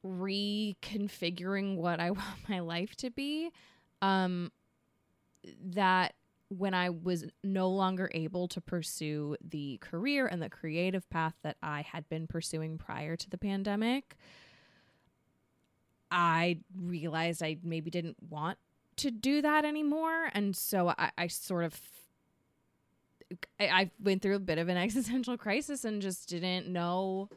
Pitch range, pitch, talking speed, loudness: 170-200 Hz, 185 Hz, 140 wpm, -34 LUFS